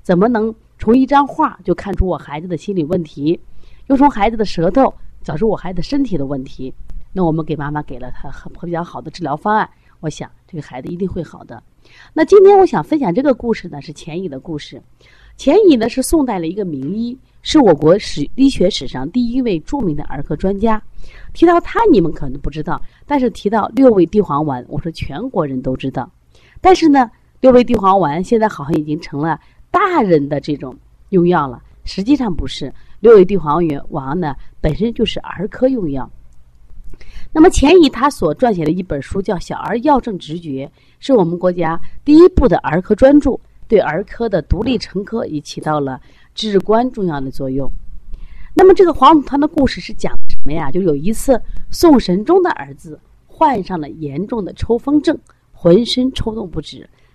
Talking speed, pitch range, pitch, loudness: 285 characters per minute, 150-245 Hz, 185 Hz, -15 LUFS